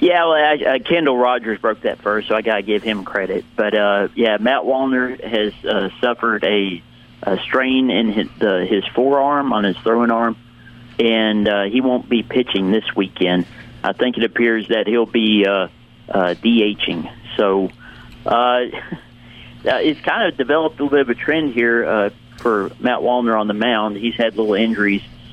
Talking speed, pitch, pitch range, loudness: 180 wpm, 115 Hz, 105-125 Hz, -17 LUFS